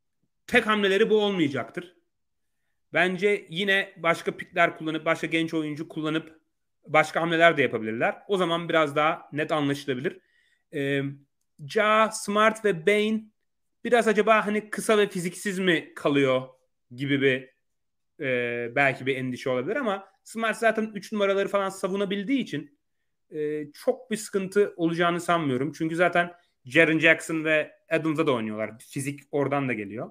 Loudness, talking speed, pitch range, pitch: -25 LUFS, 140 wpm, 145-205 Hz, 165 Hz